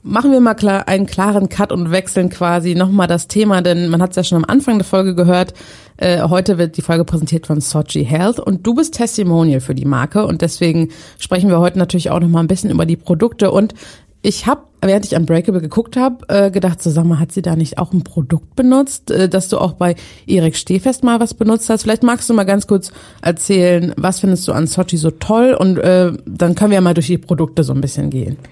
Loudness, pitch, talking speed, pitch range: -14 LUFS, 180 Hz, 235 wpm, 170-205 Hz